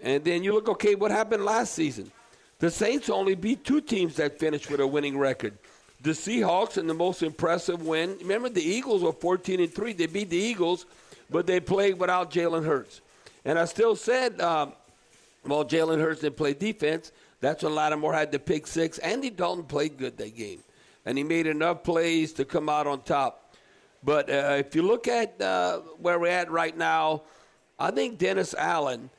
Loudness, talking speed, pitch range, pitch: -27 LUFS, 195 wpm, 155-210 Hz, 170 Hz